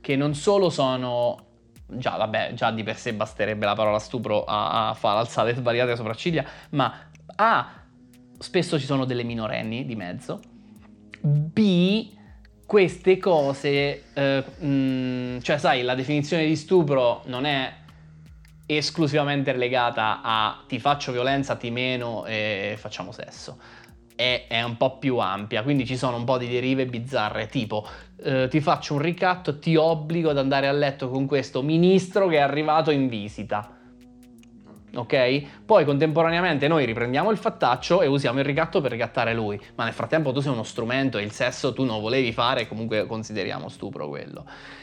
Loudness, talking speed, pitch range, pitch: -24 LUFS, 160 wpm, 115-150 Hz, 130 Hz